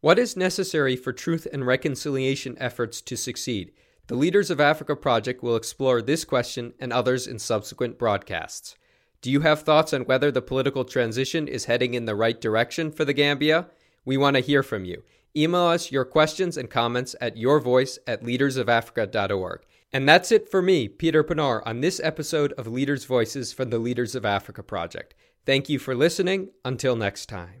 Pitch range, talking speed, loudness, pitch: 120-155 Hz, 185 wpm, -24 LUFS, 130 Hz